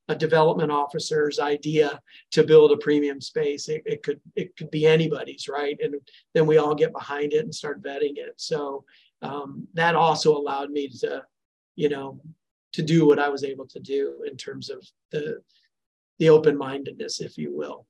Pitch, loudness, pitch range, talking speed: 155 Hz, -23 LUFS, 145-215 Hz, 180 wpm